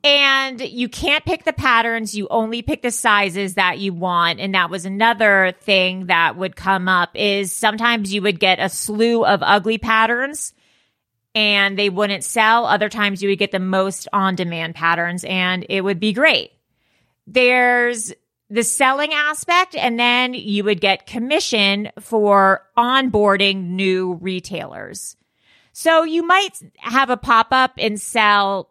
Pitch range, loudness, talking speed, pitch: 190-240 Hz, -17 LUFS, 155 wpm, 210 Hz